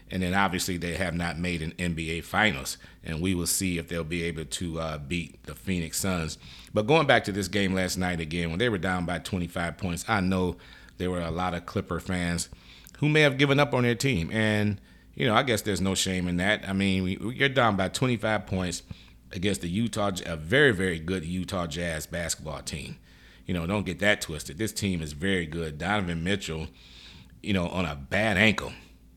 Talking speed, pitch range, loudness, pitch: 215 wpm, 85-100 Hz, -27 LUFS, 90 Hz